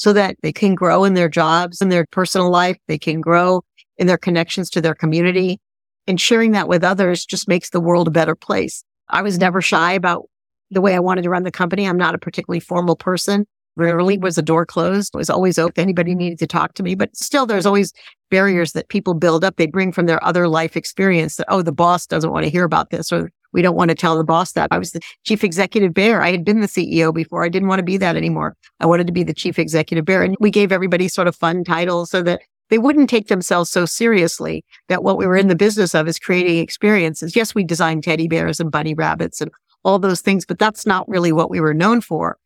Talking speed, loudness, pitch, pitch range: 250 wpm, -17 LUFS, 180 Hz, 165-195 Hz